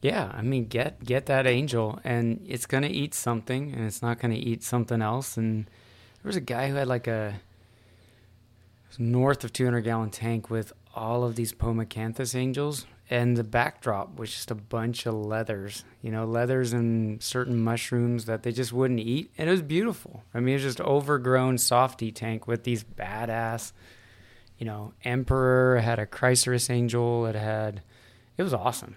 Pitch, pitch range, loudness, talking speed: 120 Hz, 110-125 Hz, -27 LUFS, 180 wpm